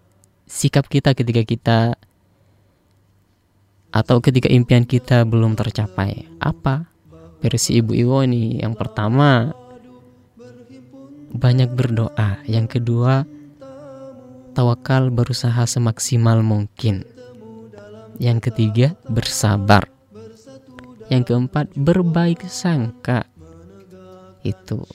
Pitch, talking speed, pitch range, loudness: 120 Hz, 80 wpm, 110-130 Hz, -18 LUFS